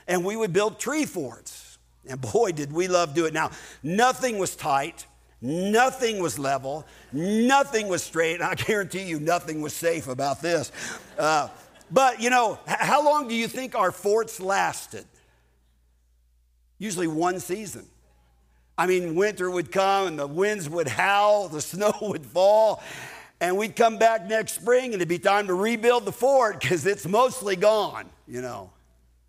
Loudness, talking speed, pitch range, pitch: -24 LUFS, 170 wpm, 145-215 Hz, 180 Hz